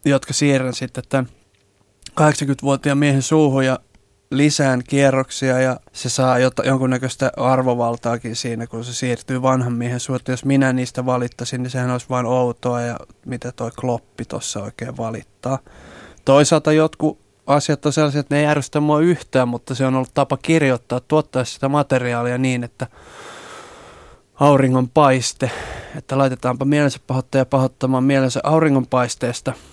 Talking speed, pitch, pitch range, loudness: 140 wpm, 130 Hz, 125-140 Hz, -19 LUFS